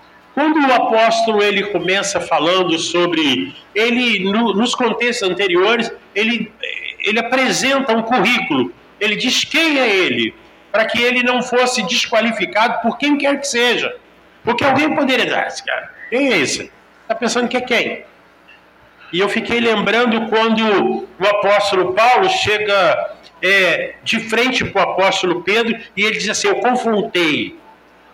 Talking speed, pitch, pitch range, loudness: 150 wpm, 230 Hz, 205-265 Hz, -15 LUFS